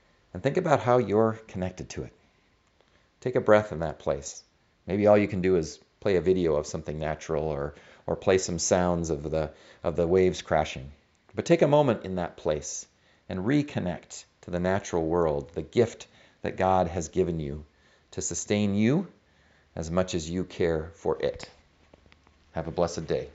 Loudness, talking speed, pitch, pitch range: -27 LUFS, 185 wpm, 90 Hz, 80-105 Hz